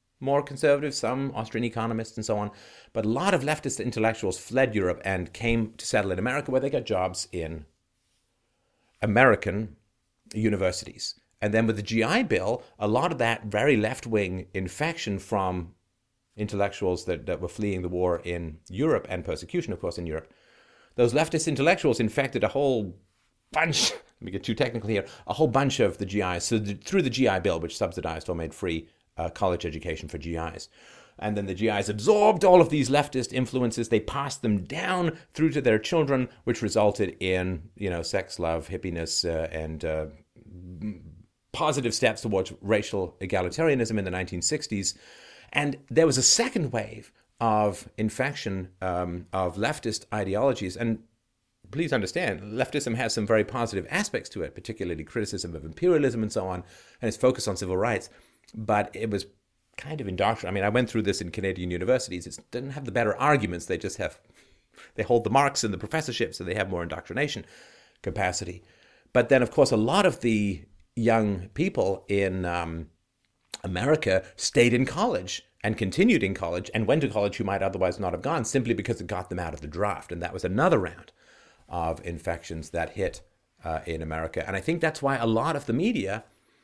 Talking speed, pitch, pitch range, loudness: 185 wpm, 105 Hz, 90-125 Hz, -27 LUFS